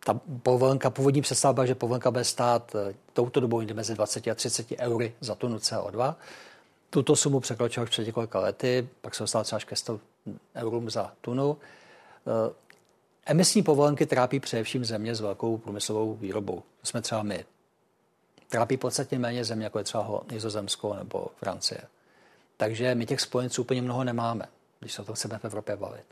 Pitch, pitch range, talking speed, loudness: 120 Hz, 110-130 Hz, 165 wpm, -28 LUFS